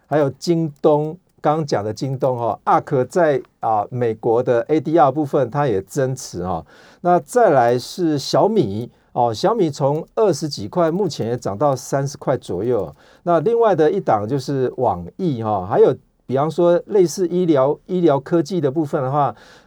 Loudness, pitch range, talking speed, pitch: -19 LUFS, 130-165 Hz, 260 characters per minute, 150 Hz